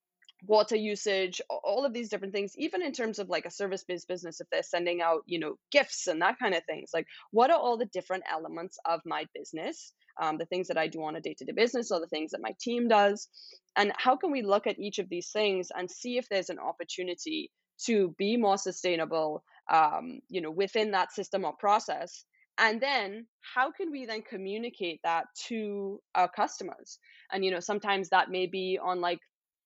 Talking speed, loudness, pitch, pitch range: 205 wpm, -31 LUFS, 200 Hz, 180-235 Hz